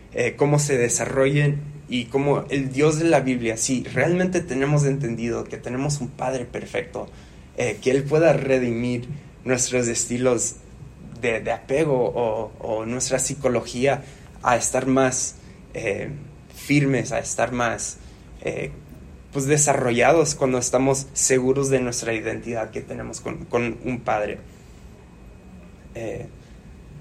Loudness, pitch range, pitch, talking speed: -22 LUFS, 120-140 Hz, 130 Hz, 130 wpm